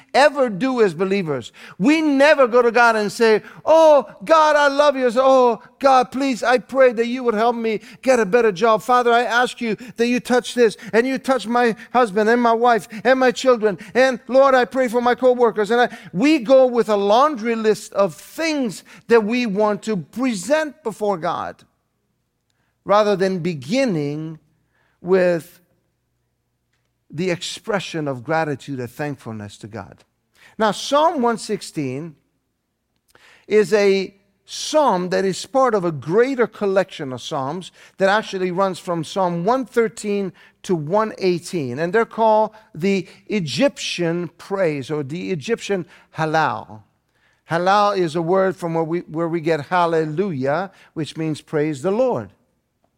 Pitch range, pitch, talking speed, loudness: 170-245 Hz, 210 Hz, 155 wpm, -19 LUFS